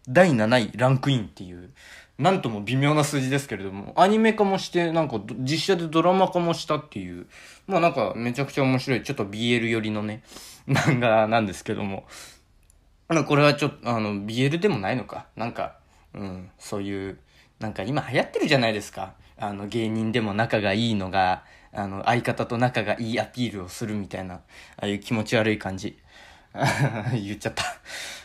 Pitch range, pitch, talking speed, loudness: 100-140 Hz, 115 Hz, 375 characters per minute, -24 LUFS